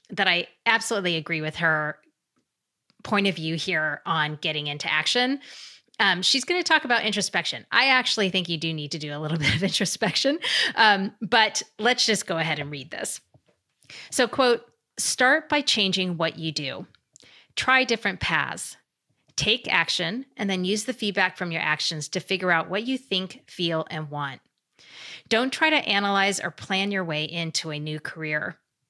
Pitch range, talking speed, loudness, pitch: 160-225 Hz, 175 wpm, -24 LUFS, 190 Hz